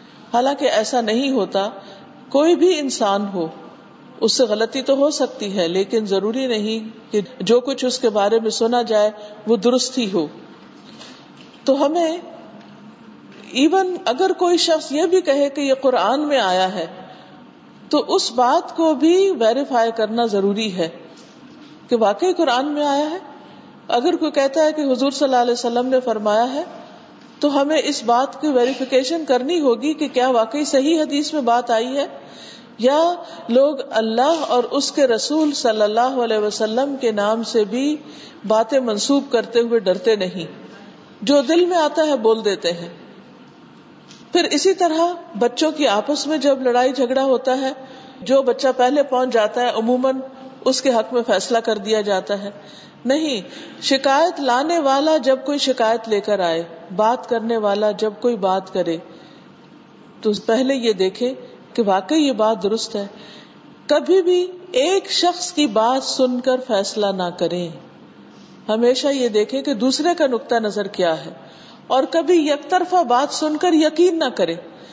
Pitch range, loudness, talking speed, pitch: 220-290 Hz, -18 LUFS, 165 wpm, 255 Hz